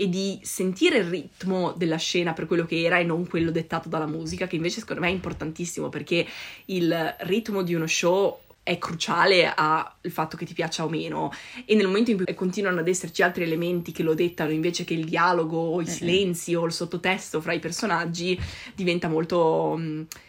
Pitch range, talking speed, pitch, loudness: 165-185 Hz, 200 wpm, 175 Hz, -25 LUFS